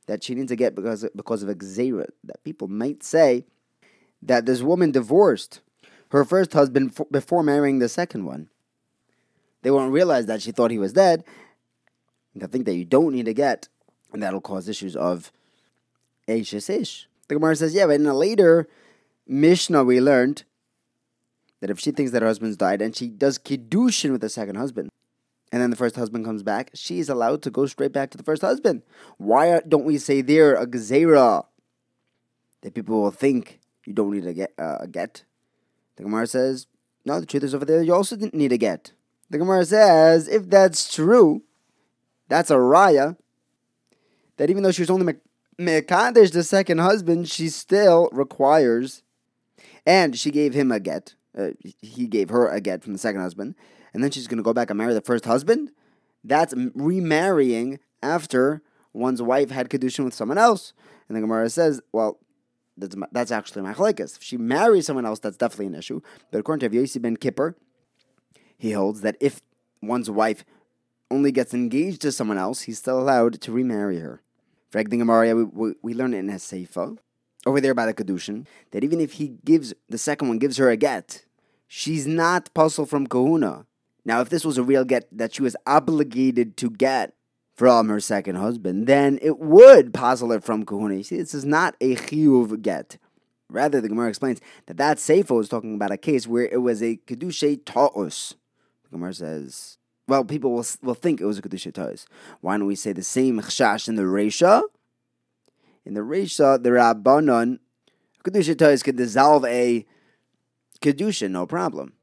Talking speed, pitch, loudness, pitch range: 185 wpm, 130 Hz, -21 LUFS, 110-155 Hz